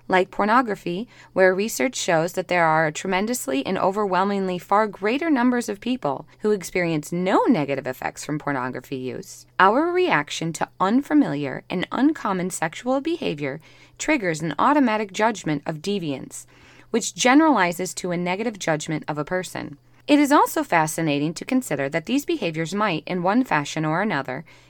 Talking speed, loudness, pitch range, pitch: 155 wpm, -22 LUFS, 155-230 Hz, 185 Hz